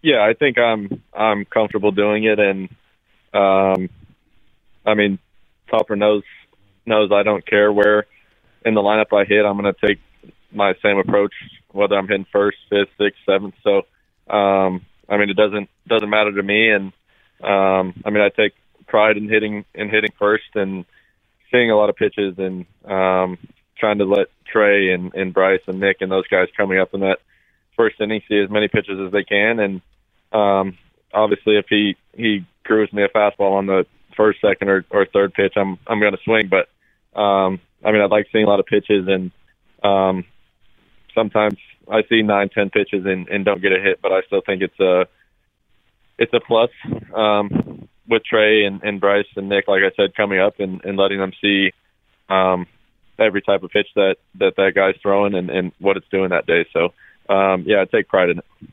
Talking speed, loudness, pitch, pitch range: 195 wpm, -18 LUFS, 100 Hz, 95-105 Hz